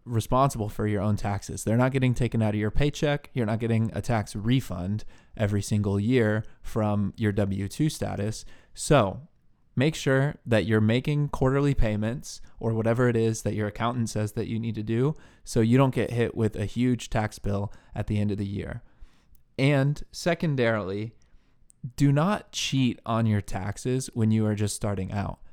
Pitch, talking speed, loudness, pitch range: 115 Hz, 185 wpm, -27 LUFS, 105-125 Hz